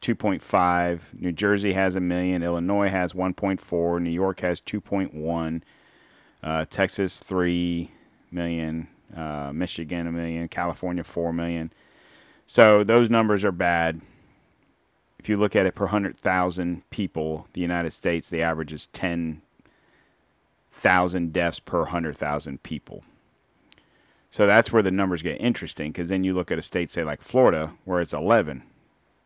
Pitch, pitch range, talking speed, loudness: 85 Hz, 85-95 Hz, 145 wpm, -24 LUFS